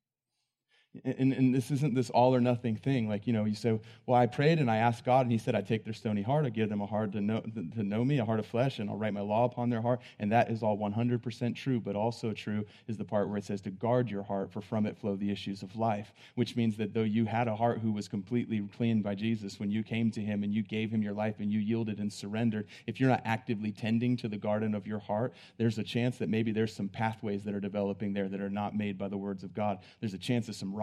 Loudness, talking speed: -32 LUFS, 280 wpm